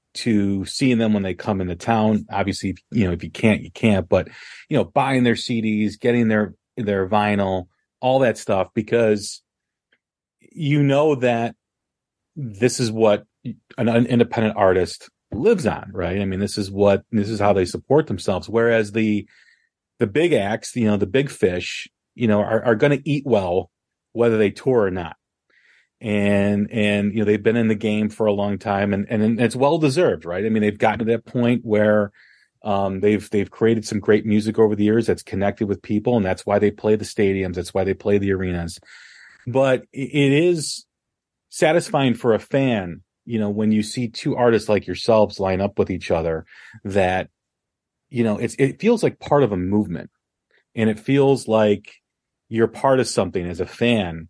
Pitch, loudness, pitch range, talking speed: 110 Hz, -20 LUFS, 100-120 Hz, 190 wpm